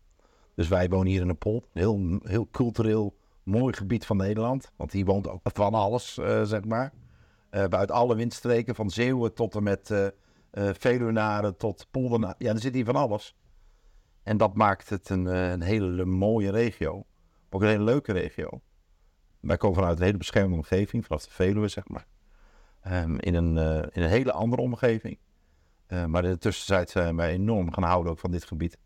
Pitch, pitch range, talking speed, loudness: 100 Hz, 90-110 Hz, 195 wpm, -27 LUFS